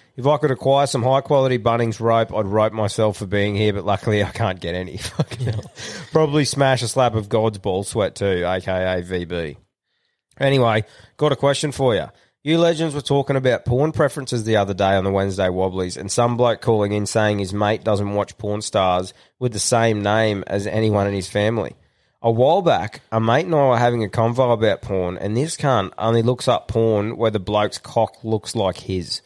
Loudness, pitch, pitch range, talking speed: -20 LUFS, 110 Hz, 100-130 Hz, 205 wpm